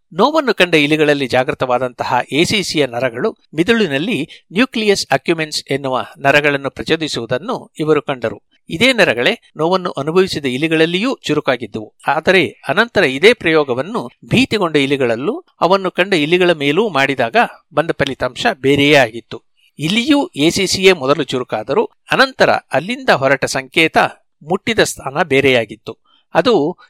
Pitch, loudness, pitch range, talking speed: 155 Hz, -15 LUFS, 135-185 Hz, 105 wpm